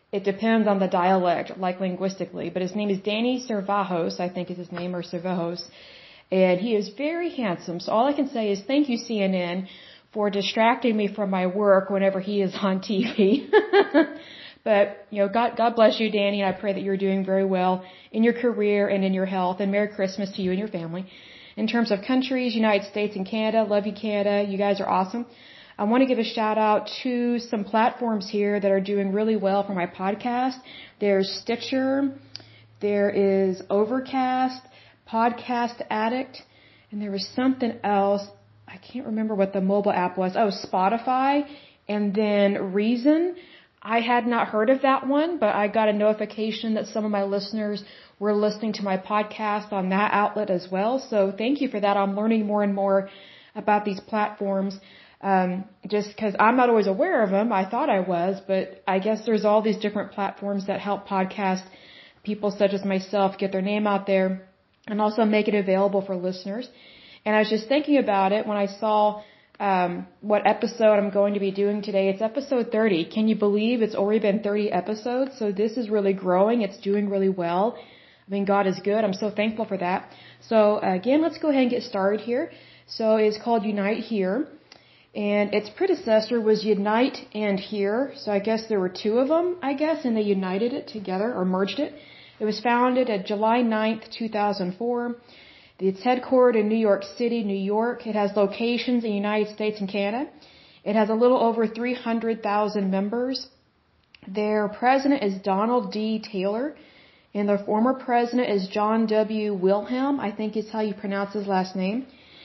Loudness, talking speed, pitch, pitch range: -24 LUFS, 190 wpm, 210 Hz, 195-230 Hz